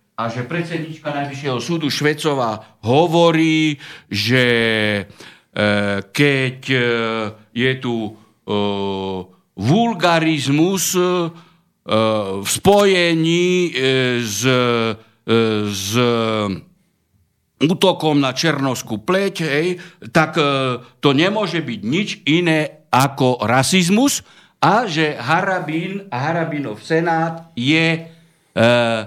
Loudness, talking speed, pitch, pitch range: -17 LUFS, 70 wpm, 140 Hz, 115-165 Hz